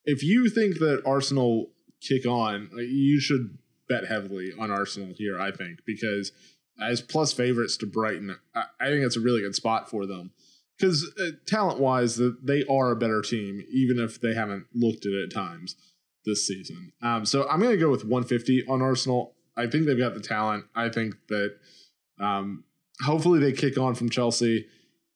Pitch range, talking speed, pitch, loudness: 110-140 Hz, 185 wpm, 120 Hz, -26 LUFS